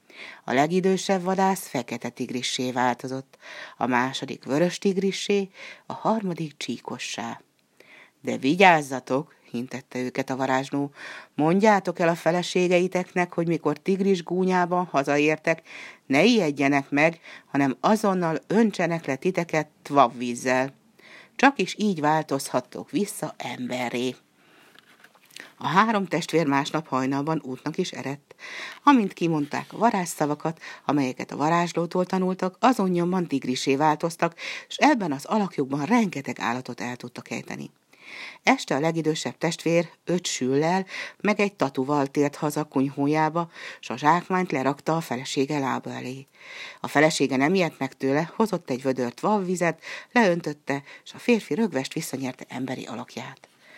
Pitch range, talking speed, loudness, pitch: 135-180 Hz, 120 wpm, -25 LUFS, 155 Hz